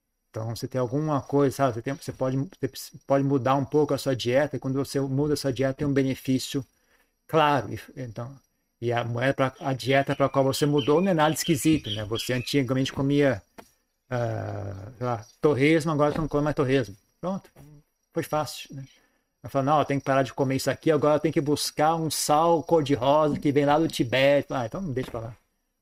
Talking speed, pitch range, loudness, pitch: 215 wpm, 130-150 Hz, -25 LUFS, 140 Hz